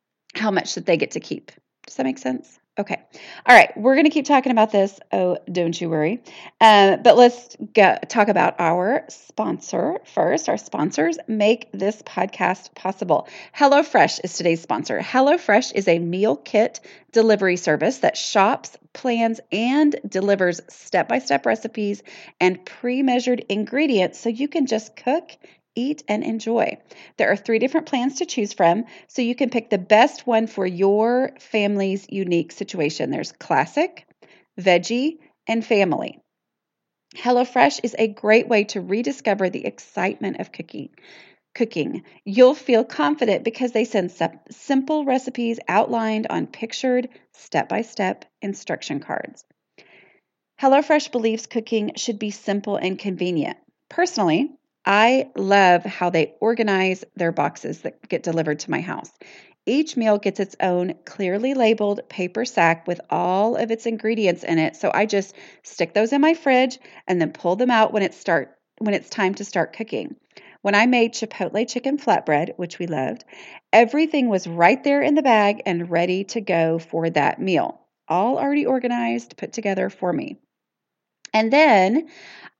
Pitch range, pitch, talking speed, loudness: 185-250 Hz, 220 Hz, 155 wpm, -20 LUFS